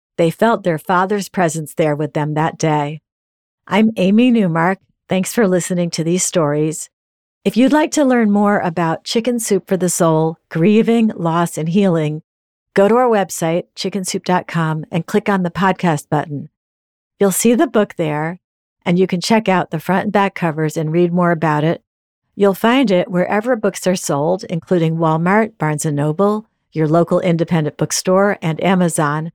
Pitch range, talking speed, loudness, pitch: 160-200 Hz, 170 wpm, -16 LUFS, 180 Hz